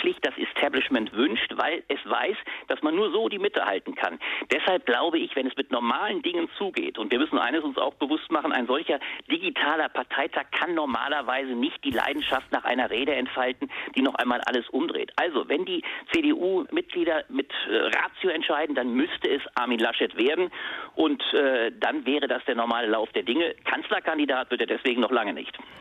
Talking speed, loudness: 185 wpm, -26 LUFS